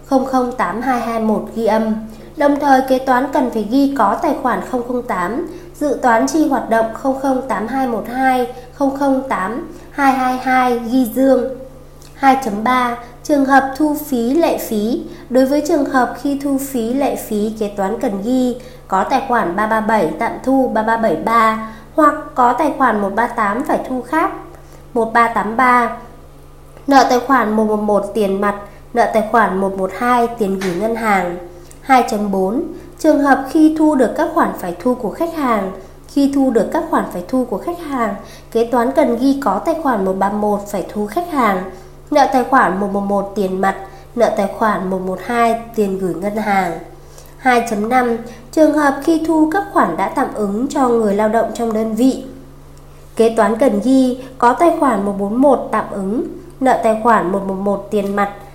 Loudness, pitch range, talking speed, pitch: -16 LUFS, 210-270 Hz, 160 wpm, 240 Hz